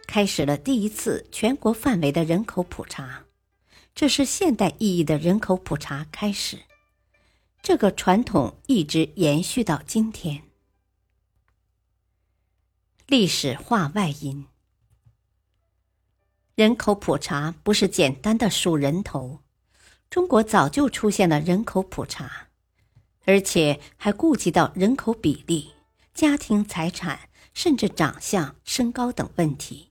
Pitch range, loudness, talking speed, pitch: 135-210 Hz, -23 LUFS, 180 characters per minute, 170 Hz